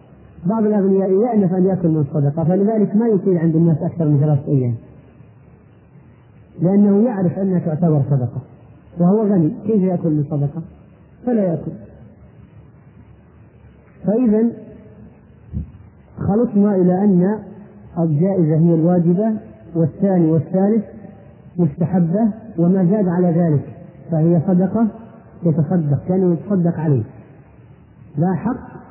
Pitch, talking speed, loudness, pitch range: 170 Hz, 110 wpm, -17 LUFS, 150-195 Hz